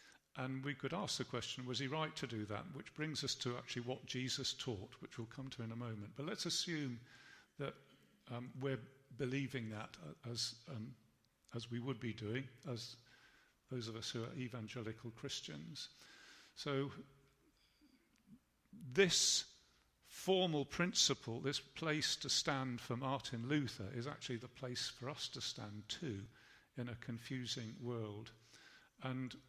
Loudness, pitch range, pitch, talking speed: -42 LUFS, 115-140 Hz, 130 Hz, 155 wpm